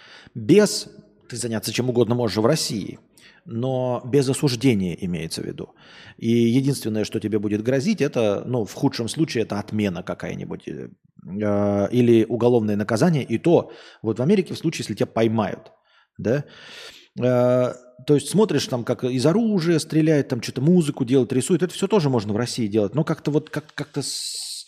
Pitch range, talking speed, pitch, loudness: 110-145 Hz, 165 wpm, 125 Hz, -22 LUFS